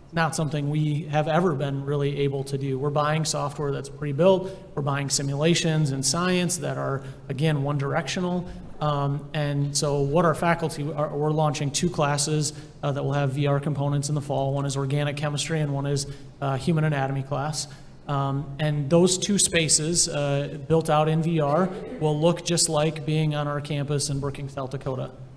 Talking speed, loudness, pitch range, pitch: 185 wpm, -25 LUFS, 140-155 Hz, 150 Hz